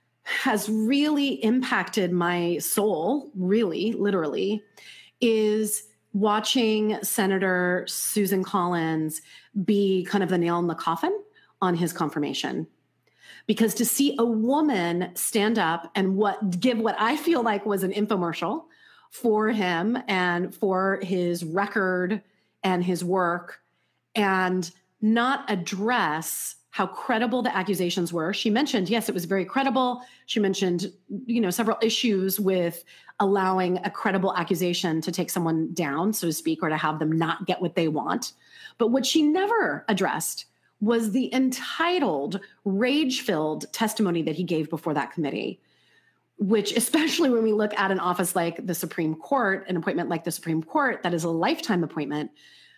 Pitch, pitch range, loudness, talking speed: 200 Hz, 175-225 Hz, -25 LUFS, 150 wpm